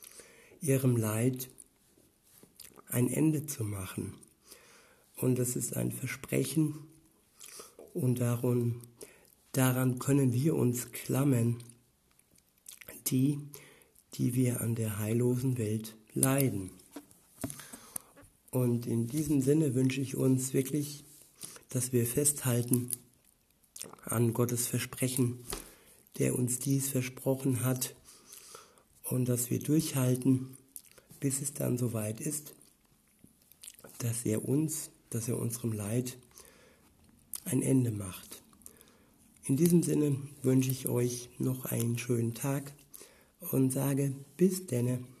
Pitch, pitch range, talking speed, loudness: 130 Hz, 120-140 Hz, 105 wpm, -32 LUFS